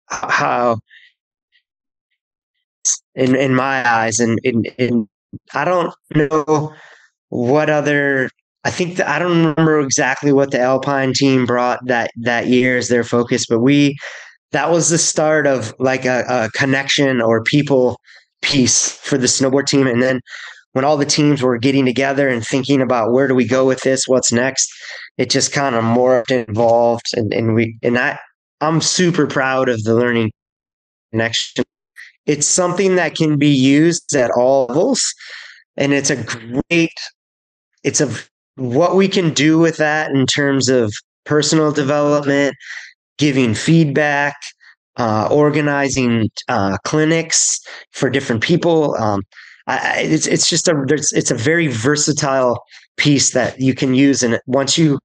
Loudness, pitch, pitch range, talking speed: -15 LUFS, 135 Hz, 125-150 Hz, 155 wpm